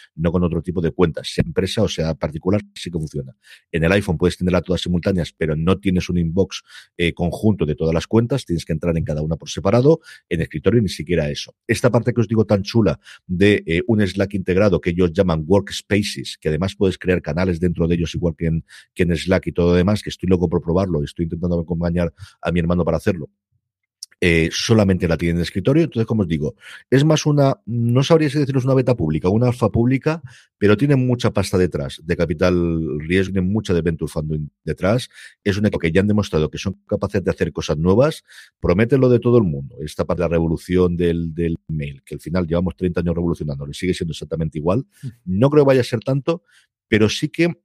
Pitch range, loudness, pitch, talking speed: 85-110 Hz, -19 LUFS, 90 Hz, 225 wpm